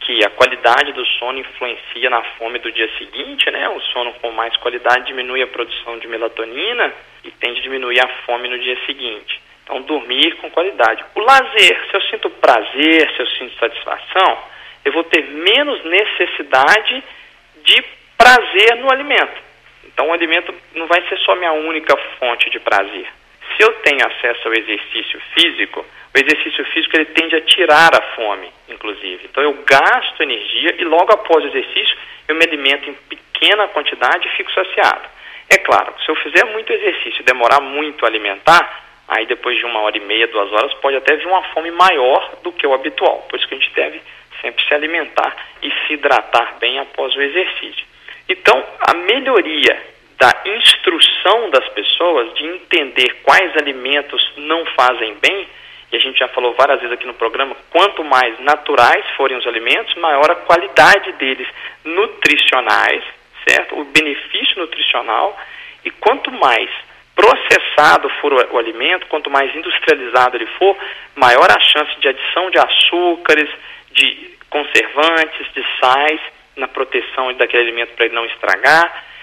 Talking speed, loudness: 165 wpm, -13 LUFS